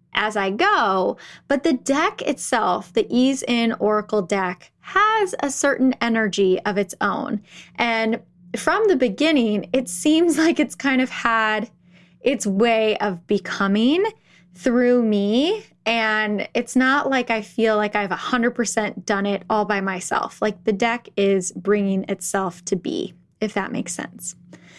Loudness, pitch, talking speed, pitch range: -21 LUFS, 220 Hz, 150 wpm, 200-255 Hz